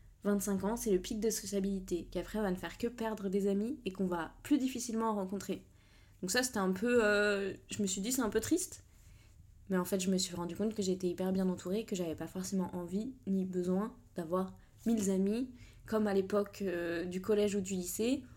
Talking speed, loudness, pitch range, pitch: 225 wpm, -35 LUFS, 185-220 Hz, 195 Hz